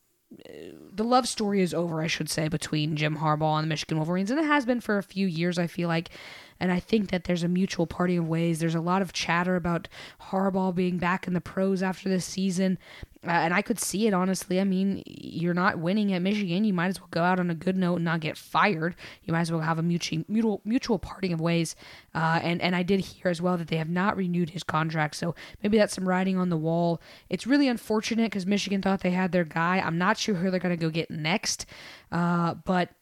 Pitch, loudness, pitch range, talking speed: 180 Hz, -27 LUFS, 165-195 Hz, 245 wpm